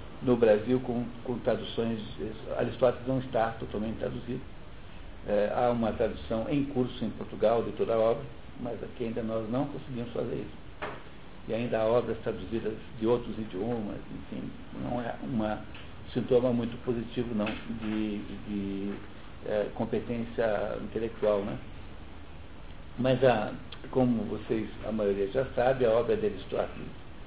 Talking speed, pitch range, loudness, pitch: 135 wpm, 105-125 Hz, -31 LUFS, 115 Hz